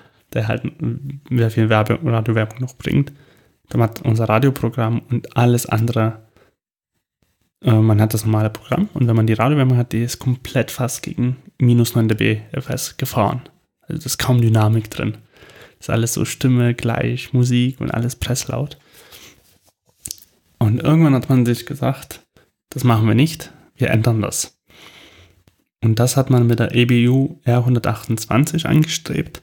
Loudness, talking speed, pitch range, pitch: -18 LUFS, 150 wpm, 115-130 Hz, 120 Hz